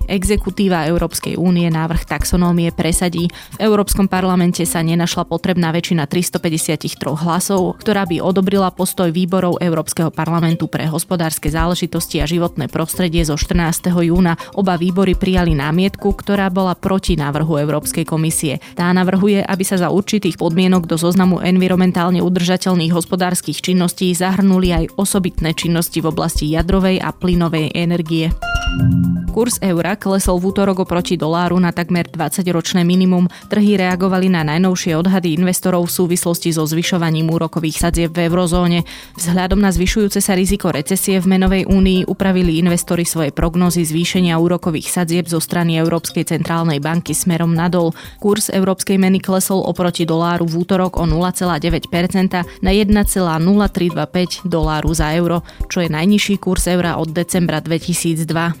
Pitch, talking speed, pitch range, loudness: 175 Hz, 140 wpm, 165-185 Hz, -16 LUFS